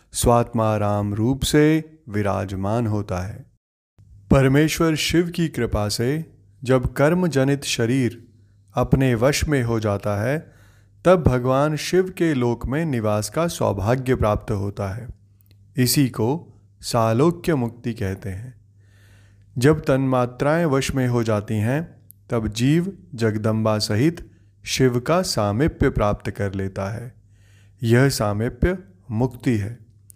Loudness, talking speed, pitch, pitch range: -21 LUFS, 120 wpm, 120 Hz, 105-135 Hz